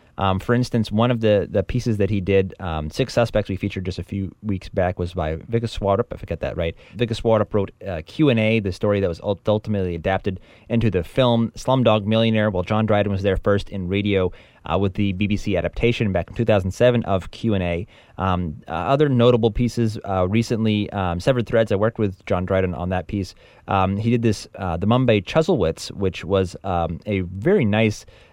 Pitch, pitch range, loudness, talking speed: 100 Hz, 95-115 Hz, -21 LUFS, 200 wpm